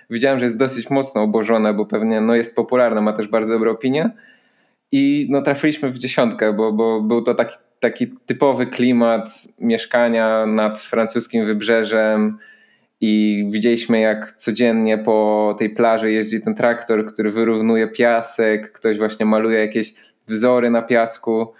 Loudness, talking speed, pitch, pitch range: -18 LUFS, 145 wpm, 115 Hz, 110-125 Hz